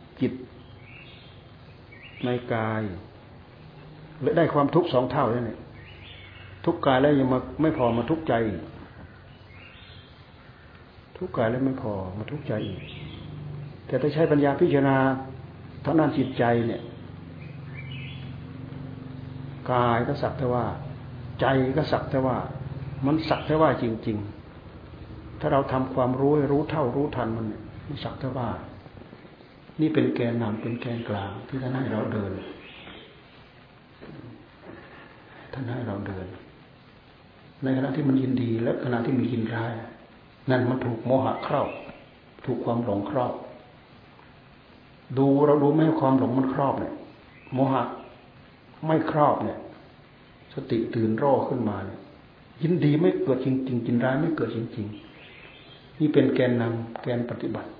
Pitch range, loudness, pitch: 115-135 Hz, -26 LUFS, 130 Hz